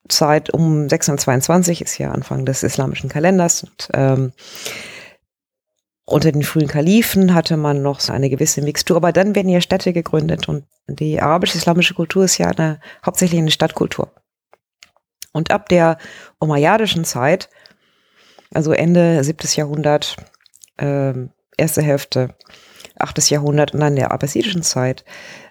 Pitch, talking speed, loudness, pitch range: 155 Hz, 135 wpm, -16 LUFS, 140-175 Hz